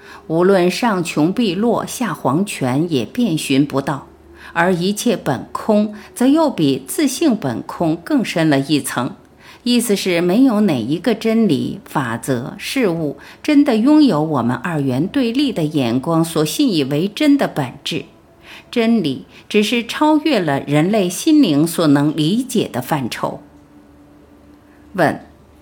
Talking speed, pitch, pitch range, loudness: 200 characters per minute, 180 Hz, 150-240 Hz, -17 LUFS